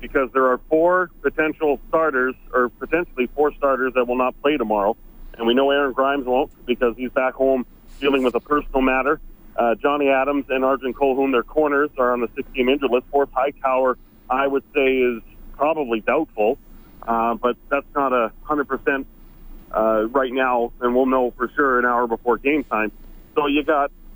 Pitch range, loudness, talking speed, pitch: 125-140 Hz, -20 LUFS, 185 wpm, 130 Hz